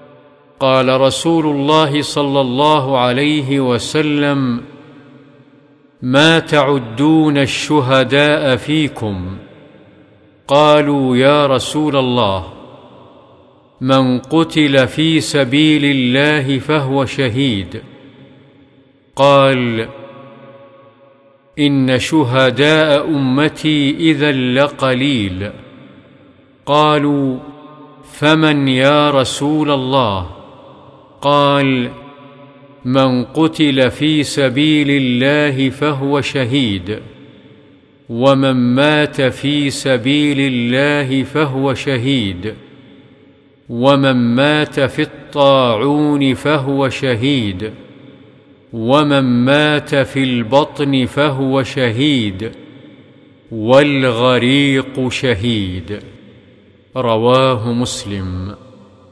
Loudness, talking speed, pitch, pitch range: -13 LUFS, 65 wpm, 140 Hz, 130-145 Hz